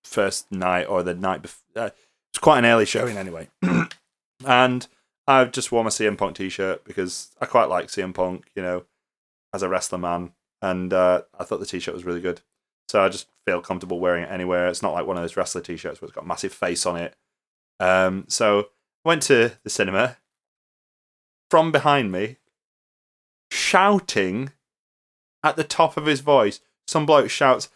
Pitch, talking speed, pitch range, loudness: 95 Hz, 185 wpm, 90-130 Hz, -22 LUFS